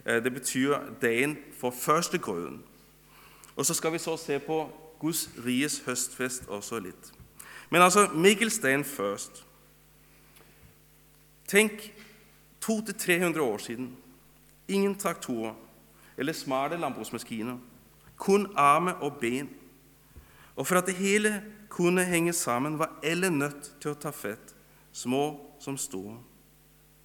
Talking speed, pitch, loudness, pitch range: 120 wpm, 145 Hz, -28 LUFS, 125-180 Hz